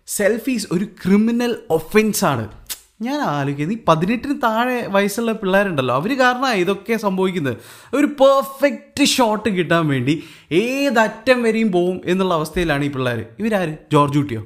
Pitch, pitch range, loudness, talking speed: 200 Hz, 160-235 Hz, -18 LUFS, 125 wpm